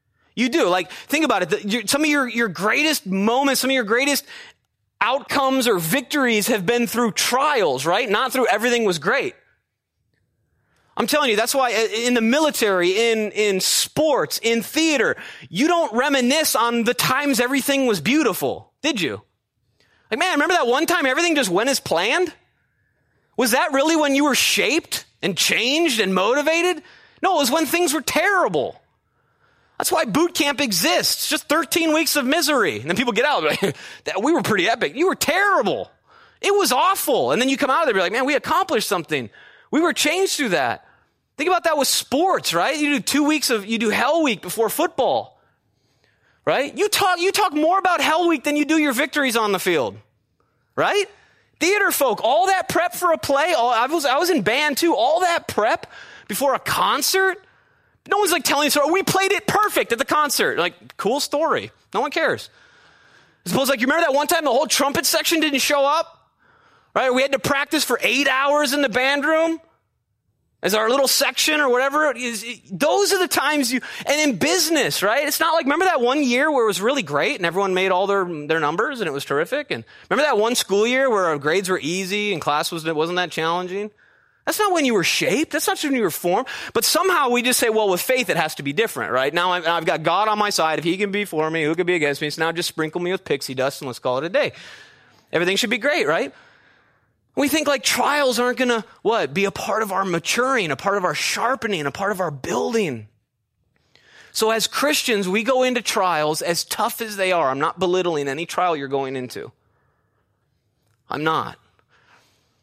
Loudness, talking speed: -19 LUFS, 205 wpm